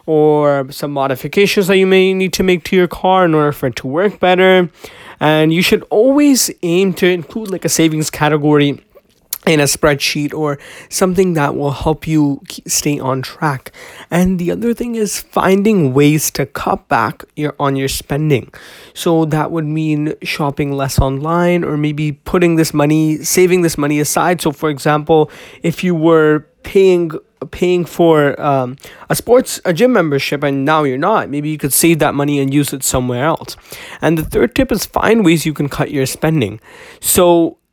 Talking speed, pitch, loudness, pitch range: 185 wpm, 155 Hz, -14 LUFS, 145-180 Hz